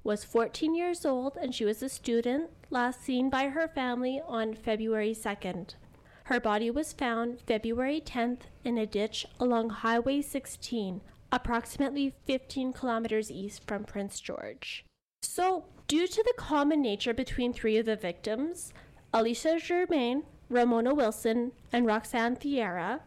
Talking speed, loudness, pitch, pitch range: 140 wpm, -31 LUFS, 245 Hz, 225-275 Hz